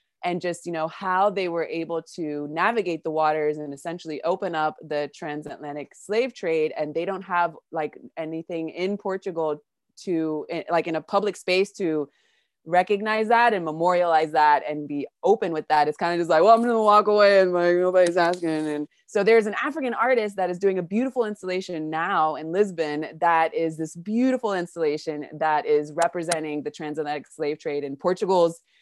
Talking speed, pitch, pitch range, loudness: 185 wpm, 170 Hz, 155-195 Hz, -24 LUFS